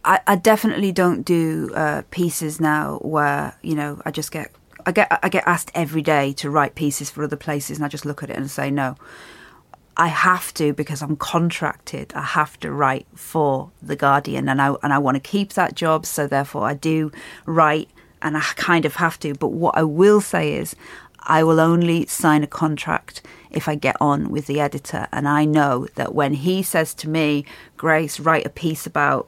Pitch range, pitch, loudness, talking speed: 145-160 Hz, 155 Hz, -20 LUFS, 205 wpm